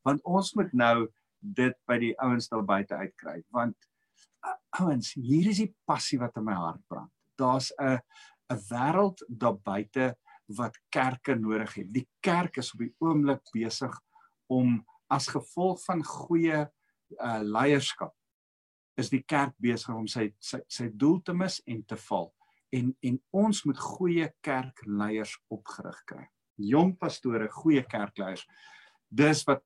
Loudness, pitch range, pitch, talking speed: -30 LUFS, 115-165 Hz, 130 Hz, 150 wpm